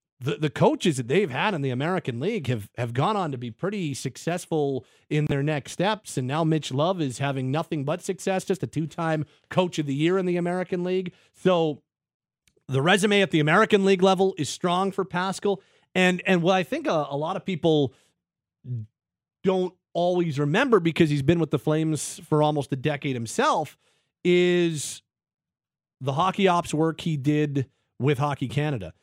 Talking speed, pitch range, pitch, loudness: 180 wpm, 145-185 Hz, 160 Hz, -25 LUFS